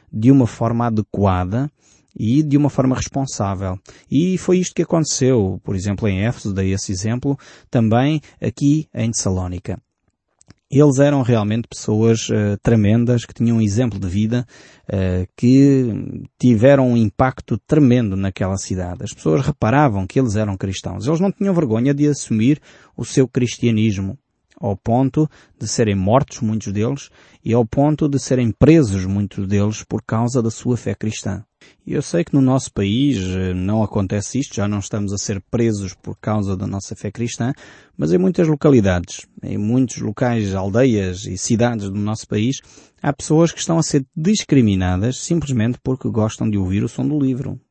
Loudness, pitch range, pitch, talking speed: -18 LUFS, 100-135 Hz, 115 Hz, 165 wpm